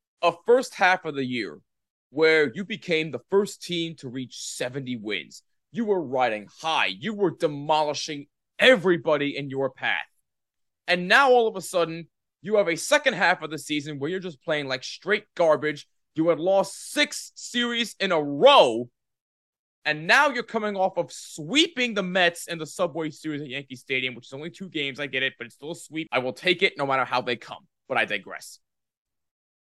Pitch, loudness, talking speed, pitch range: 160 Hz, -24 LUFS, 195 wpm, 140-195 Hz